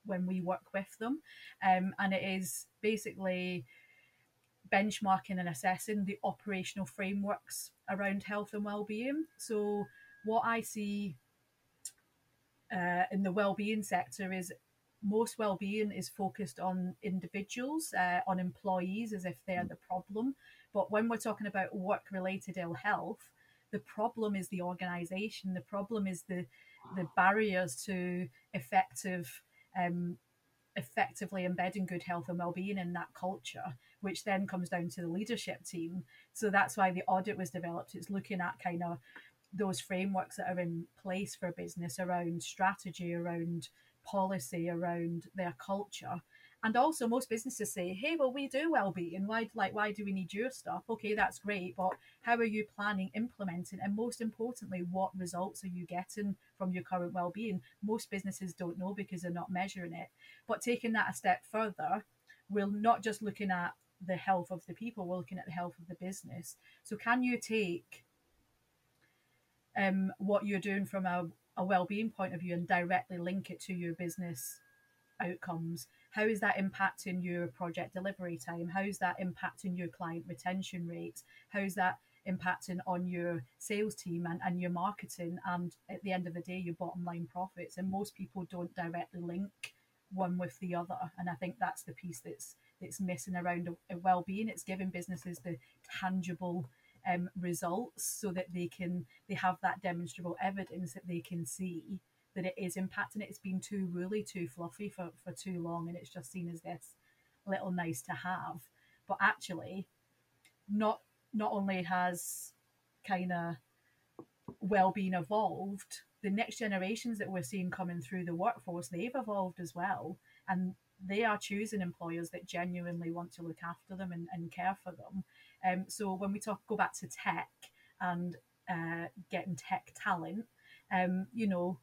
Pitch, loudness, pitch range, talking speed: 185 Hz, -37 LUFS, 175-200 Hz, 170 wpm